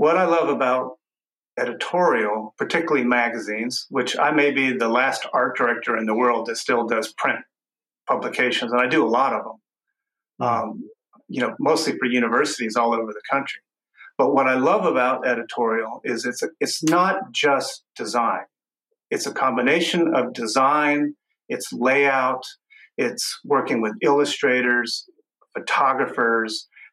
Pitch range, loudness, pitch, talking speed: 115-150 Hz, -21 LUFS, 130 Hz, 145 wpm